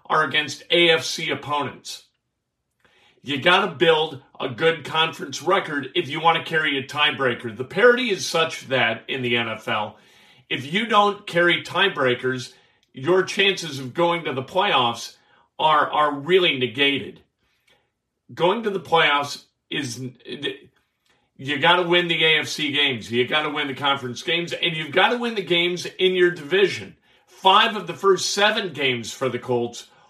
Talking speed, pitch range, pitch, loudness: 160 wpm, 130-175 Hz, 155 Hz, -21 LUFS